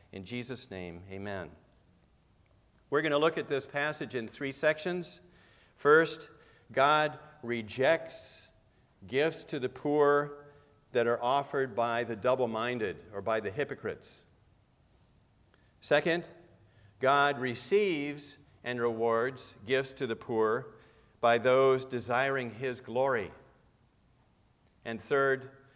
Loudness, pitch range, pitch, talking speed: -31 LUFS, 110-145 Hz, 125 Hz, 110 wpm